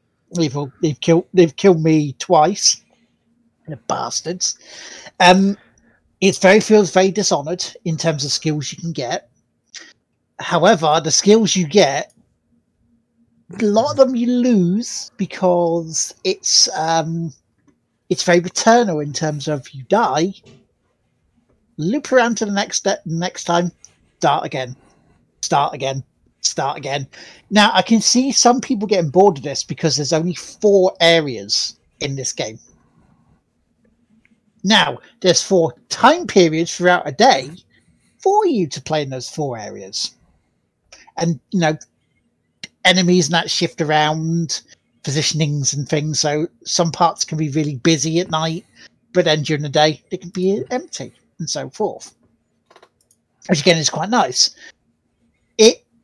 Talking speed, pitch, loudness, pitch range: 140 wpm, 170 Hz, -17 LUFS, 155-195 Hz